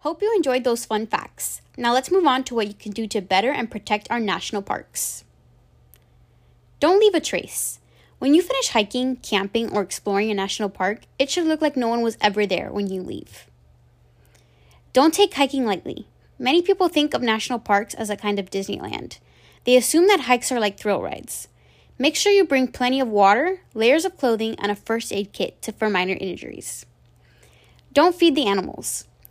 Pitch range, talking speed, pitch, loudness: 200-275 Hz, 190 wpm, 225 Hz, -21 LUFS